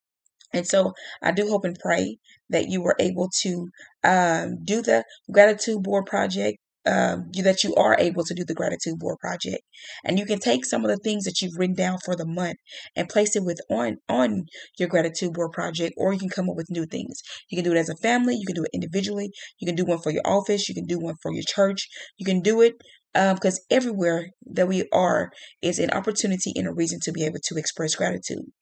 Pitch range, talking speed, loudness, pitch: 170-200 Hz, 235 wpm, -24 LUFS, 185 Hz